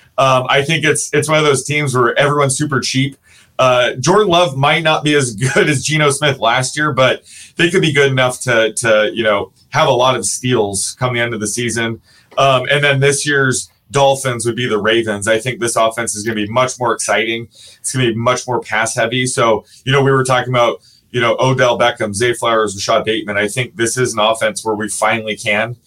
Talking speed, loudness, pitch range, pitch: 235 wpm, -14 LUFS, 110-140 Hz, 125 Hz